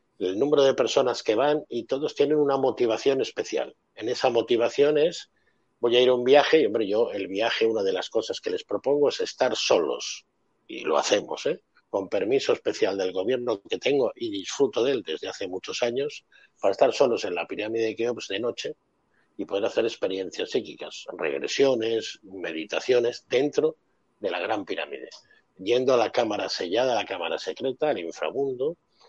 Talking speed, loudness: 185 wpm, -25 LUFS